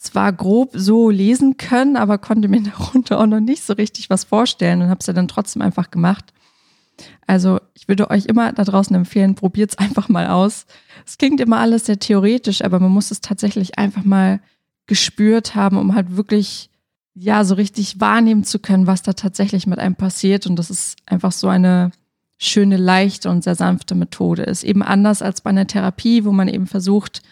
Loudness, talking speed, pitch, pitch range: -16 LUFS, 195 wpm, 200 Hz, 190-215 Hz